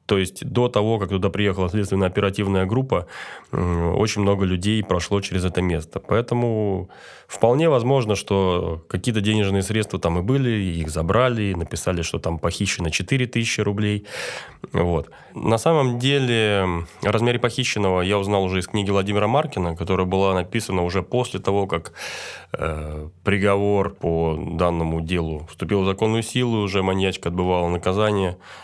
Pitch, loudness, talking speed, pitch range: 95 Hz, -22 LUFS, 140 wpm, 90-110 Hz